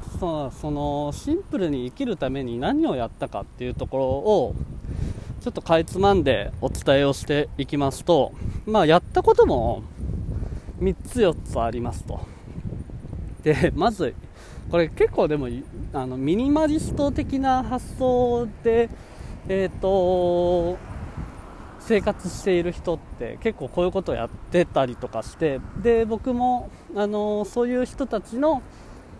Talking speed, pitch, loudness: 265 characters per minute, 175 Hz, -24 LUFS